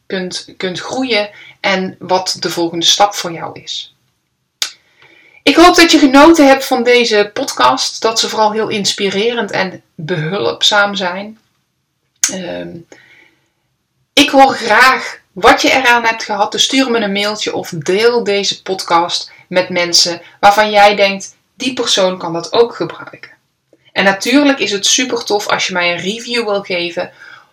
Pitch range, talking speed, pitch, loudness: 185-235 Hz, 155 wpm, 205 Hz, -12 LUFS